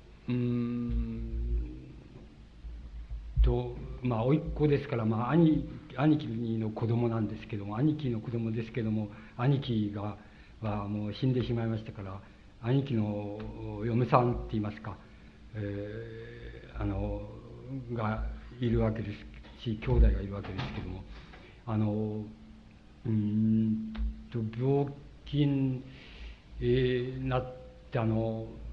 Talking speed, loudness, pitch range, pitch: 220 characters per minute, -32 LUFS, 105-125 Hz, 110 Hz